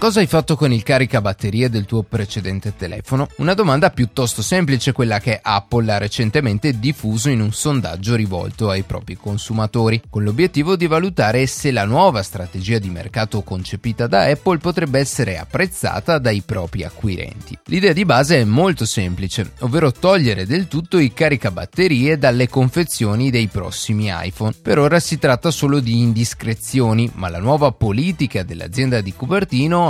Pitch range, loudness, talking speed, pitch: 105-145 Hz, -18 LUFS, 155 wpm, 120 Hz